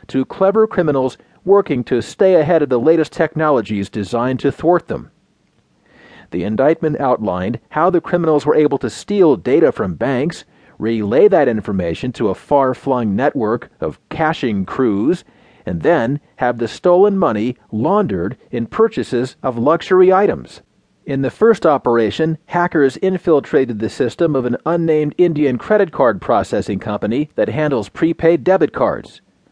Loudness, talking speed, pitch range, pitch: -16 LUFS, 145 wpm, 125-170 Hz, 150 Hz